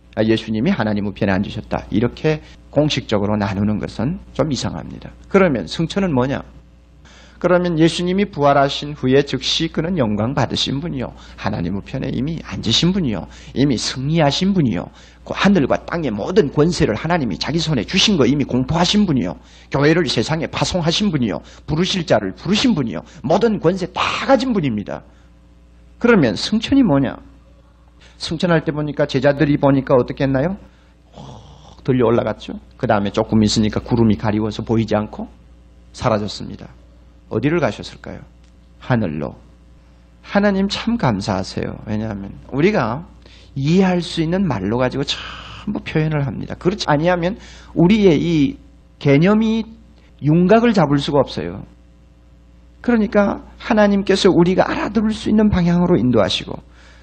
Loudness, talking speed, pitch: -18 LUFS, 330 characters per minute, 135 Hz